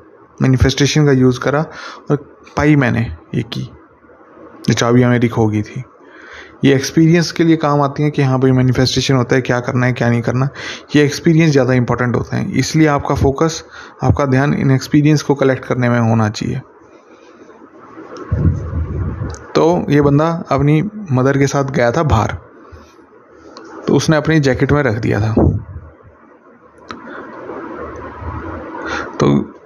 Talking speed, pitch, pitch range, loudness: 145 wpm, 130 Hz, 120-145 Hz, -15 LUFS